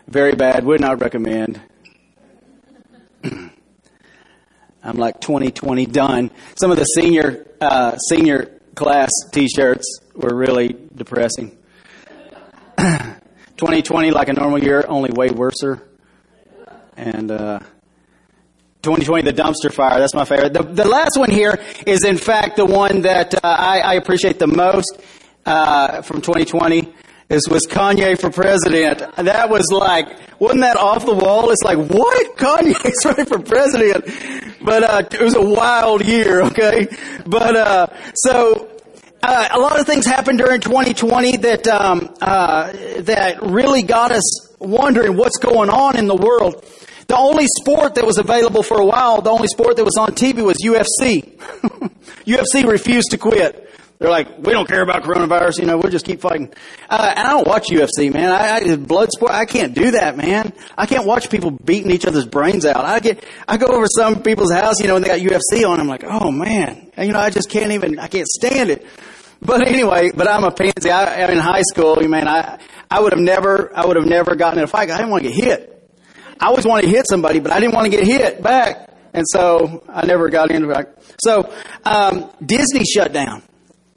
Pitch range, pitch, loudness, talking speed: 160-225 Hz, 190 Hz, -15 LUFS, 185 wpm